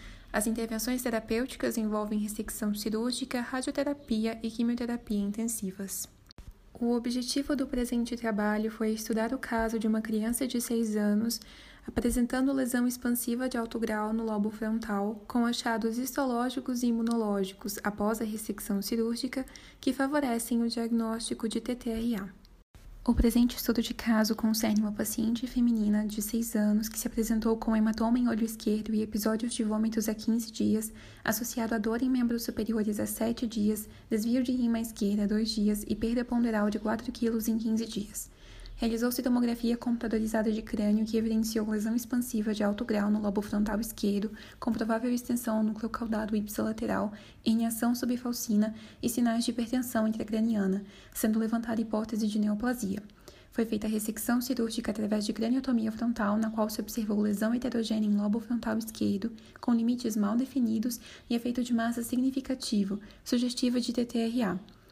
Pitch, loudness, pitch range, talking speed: 230 Hz, -30 LUFS, 215-240 Hz, 155 wpm